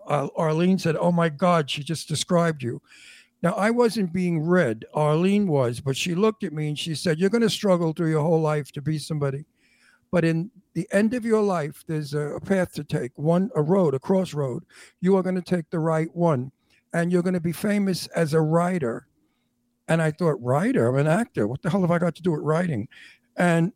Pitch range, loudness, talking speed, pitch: 150-185 Hz, -24 LUFS, 220 wpm, 165 Hz